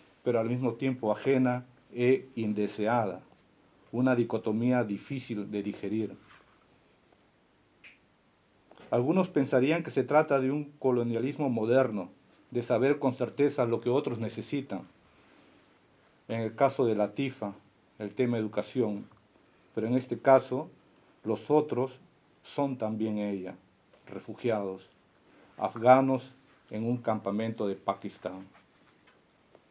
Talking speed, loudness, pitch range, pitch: 110 wpm, -30 LUFS, 105-130 Hz, 120 Hz